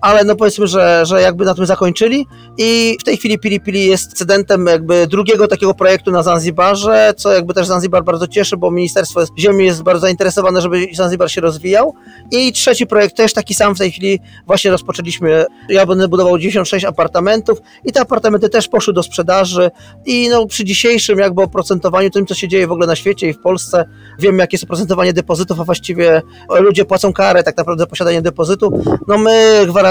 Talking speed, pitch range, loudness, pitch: 195 wpm, 180-205 Hz, -12 LUFS, 190 Hz